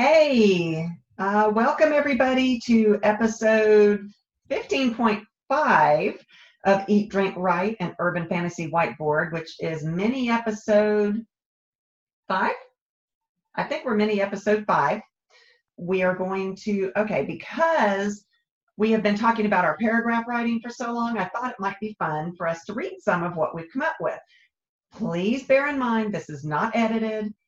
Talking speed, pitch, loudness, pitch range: 150 wpm, 210 Hz, -23 LUFS, 190-235 Hz